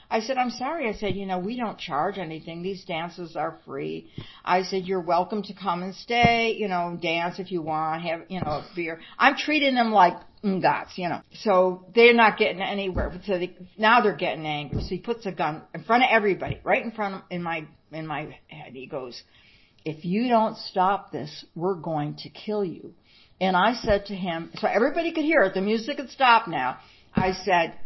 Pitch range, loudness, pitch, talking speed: 165-215 Hz, -24 LUFS, 185 Hz, 215 wpm